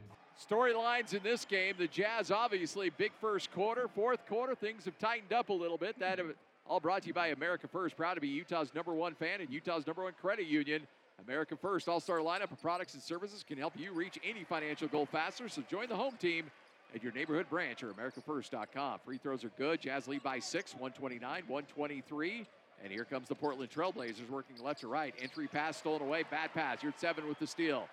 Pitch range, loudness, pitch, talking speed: 145-200 Hz, -38 LUFS, 165 Hz, 215 wpm